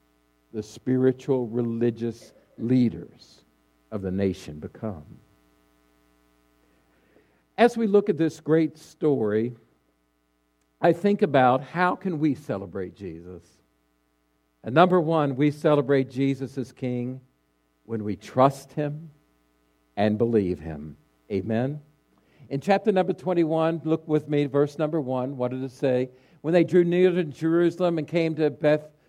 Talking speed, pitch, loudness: 130 wpm, 130 Hz, -24 LUFS